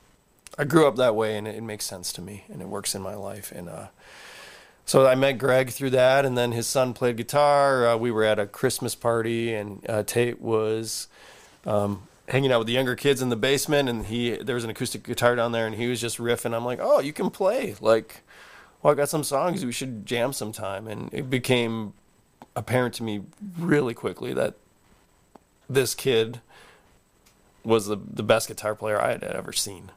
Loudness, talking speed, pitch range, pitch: -25 LUFS, 205 wpm, 110-130 Hz, 120 Hz